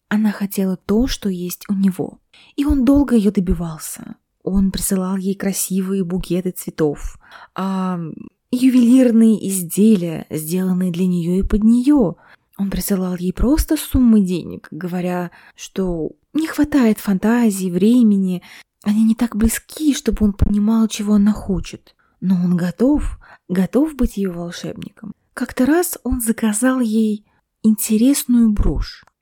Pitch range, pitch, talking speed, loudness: 185-235 Hz, 205 Hz, 130 wpm, -18 LUFS